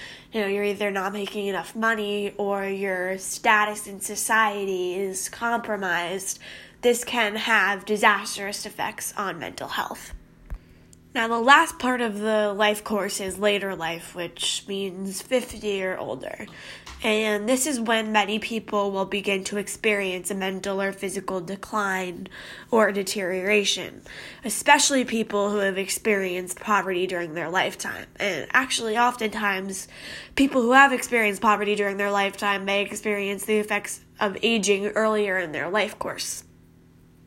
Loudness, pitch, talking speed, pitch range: -24 LUFS, 205 Hz, 140 wpm, 195-220 Hz